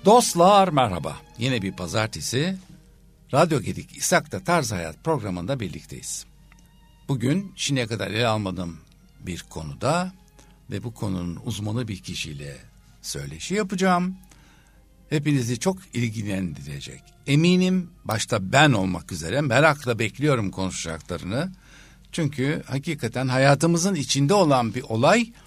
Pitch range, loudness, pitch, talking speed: 105-165 Hz, -23 LUFS, 135 Hz, 105 wpm